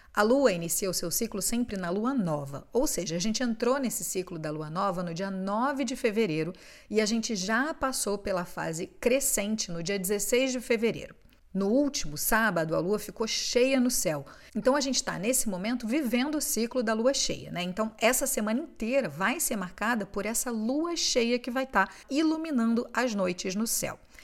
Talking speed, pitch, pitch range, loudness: 200 wpm, 225 Hz, 195-255 Hz, -28 LUFS